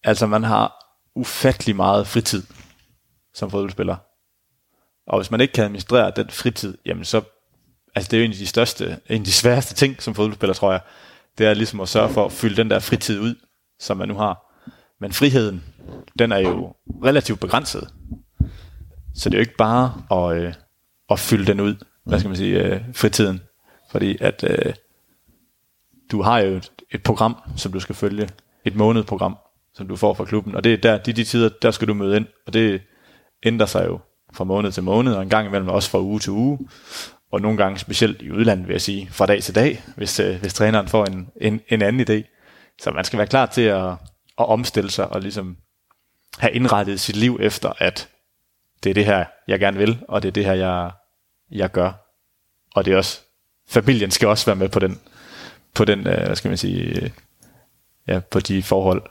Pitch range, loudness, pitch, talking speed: 95-115 Hz, -20 LUFS, 105 Hz, 200 wpm